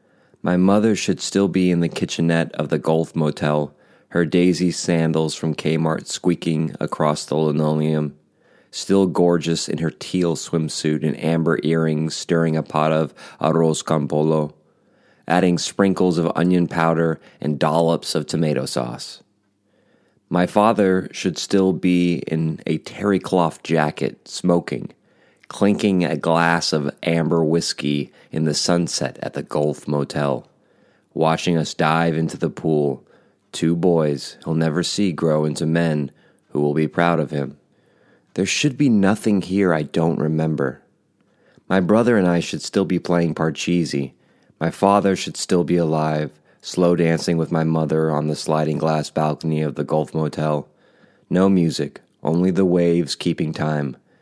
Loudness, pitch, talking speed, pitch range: -20 LUFS, 80 Hz, 150 wpm, 75-85 Hz